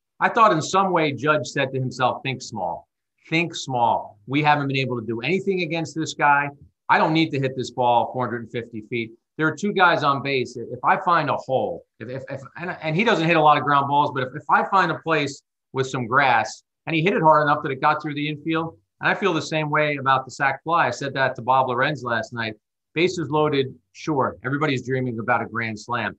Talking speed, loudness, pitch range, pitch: 245 wpm, -22 LUFS, 125-160 Hz, 145 Hz